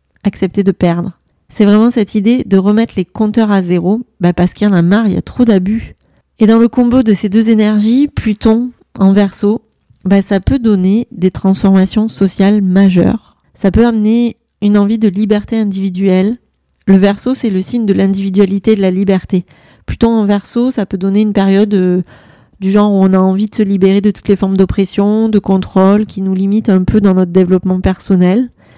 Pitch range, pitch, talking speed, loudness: 190-215 Hz, 200 Hz, 200 wpm, -11 LUFS